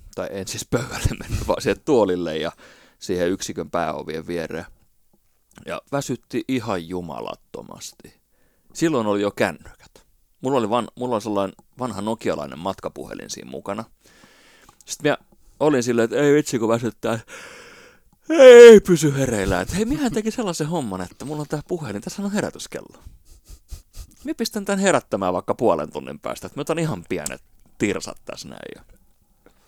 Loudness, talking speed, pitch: -20 LUFS, 150 wpm, 125 Hz